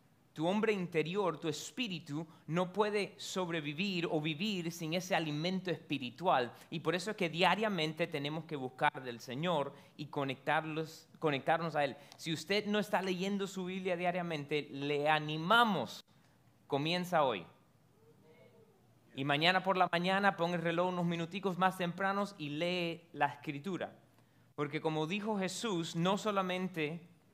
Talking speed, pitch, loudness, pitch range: 140 wpm, 170 Hz, -35 LUFS, 155-185 Hz